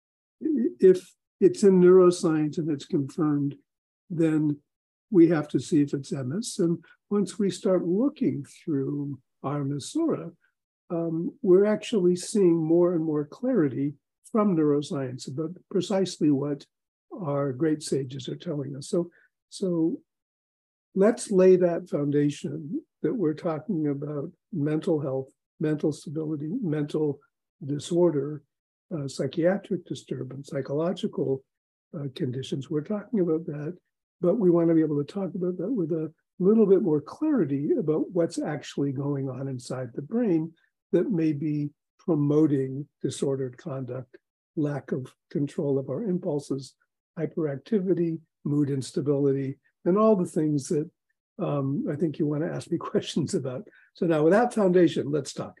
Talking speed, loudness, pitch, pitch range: 135 wpm, -26 LUFS, 160 Hz, 145-180 Hz